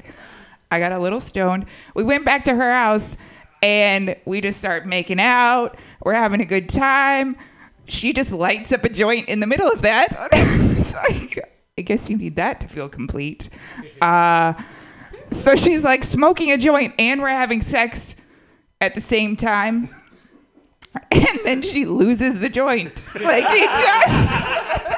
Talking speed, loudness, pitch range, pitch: 160 wpm, -17 LUFS, 190-265 Hz, 220 Hz